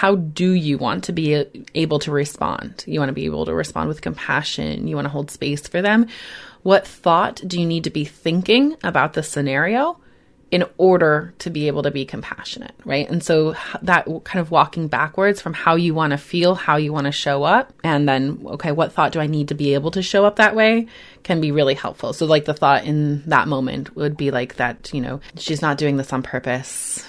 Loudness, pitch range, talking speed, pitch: -19 LUFS, 140-175 Hz, 230 wpm, 155 Hz